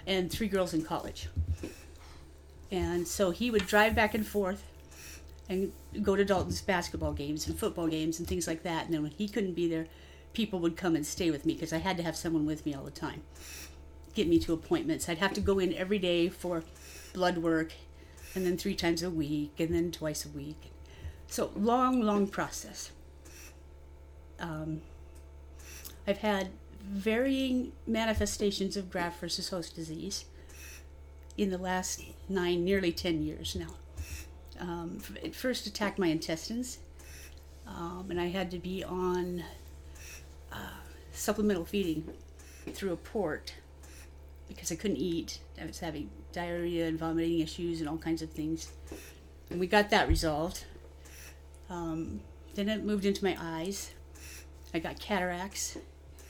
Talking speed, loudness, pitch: 160 wpm, -33 LUFS, 160 Hz